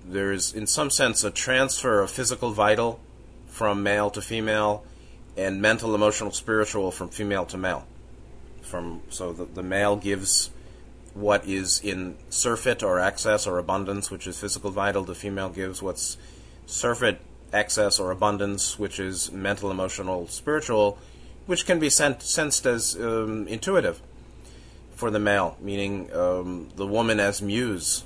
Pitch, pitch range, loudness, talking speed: 100 Hz, 95-110 Hz, -25 LUFS, 150 wpm